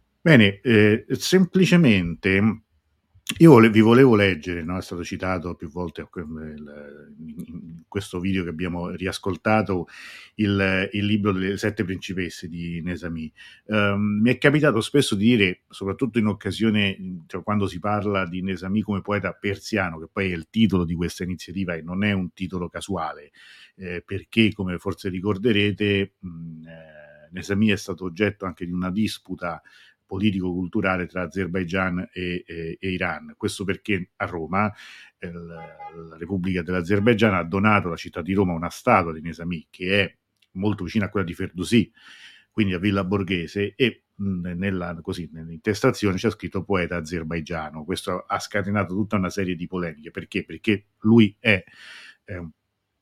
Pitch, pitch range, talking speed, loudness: 95 Hz, 90-105 Hz, 155 wpm, -23 LUFS